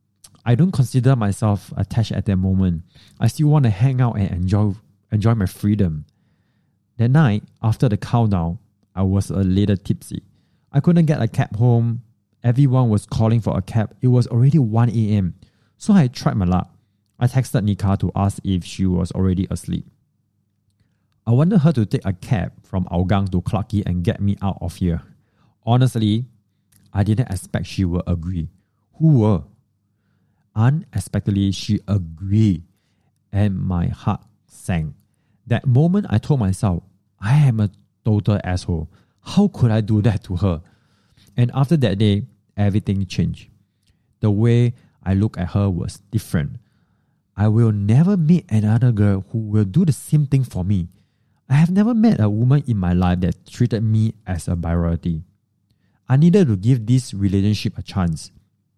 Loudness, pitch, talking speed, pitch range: -19 LUFS, 105 Hz, 165 wpm, 95-120 Hz